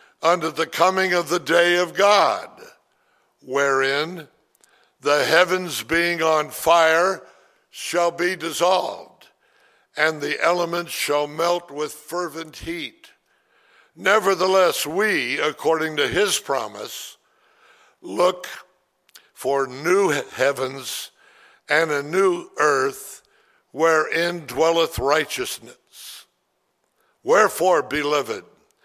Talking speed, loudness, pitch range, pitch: 90 wpm, -20 LUFS, 155-185 Hz, 170 Hz